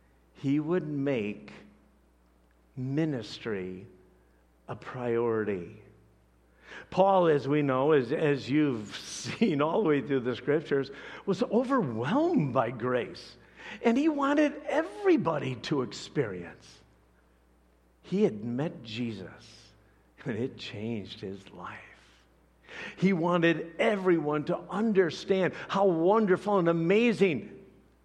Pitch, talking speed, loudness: 135 Hz, 105 wpm, -28 LUFS